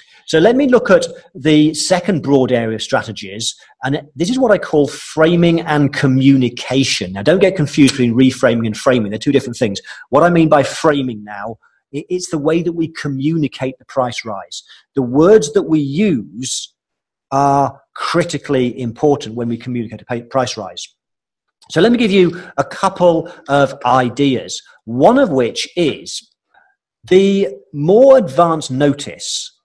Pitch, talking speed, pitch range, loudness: 145 Hz, 160 wpm, 130-175 Hz, -15 LUFS